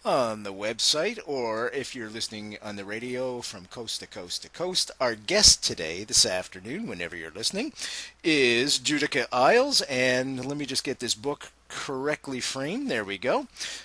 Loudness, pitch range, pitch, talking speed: -26 LUFS, 105-140 Hz, 125 Hz, 170 wpm